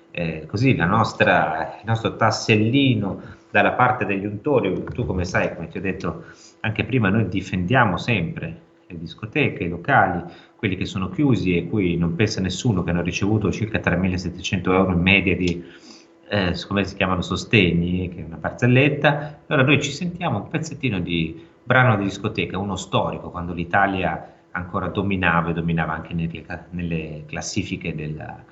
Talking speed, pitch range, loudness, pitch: 160 wpm, 85-110 Hz, -21 LUFS, 95 Hz